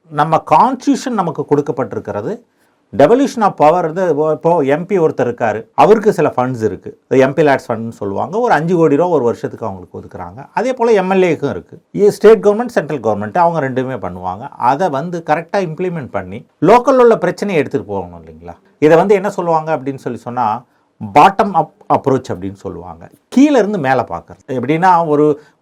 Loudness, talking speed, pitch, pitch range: -14 LUFS, 160 wpm, 155 Hz, 130-195 Hz